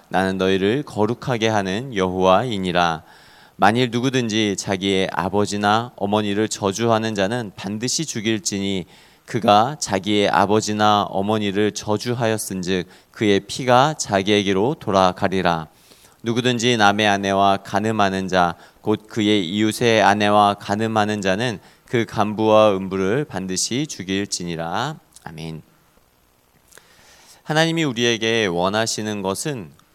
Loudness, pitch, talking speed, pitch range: -20 LUFS, 105 Hz, 280 characters per minute, 95-115 Hz